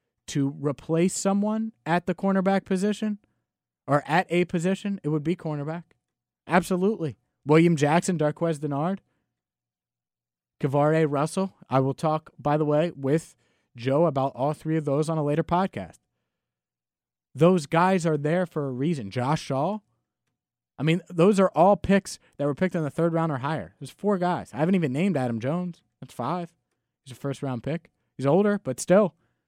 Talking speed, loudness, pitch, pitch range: 170 wpm, -25 LUFS, 160 Hz, 140-180 Hz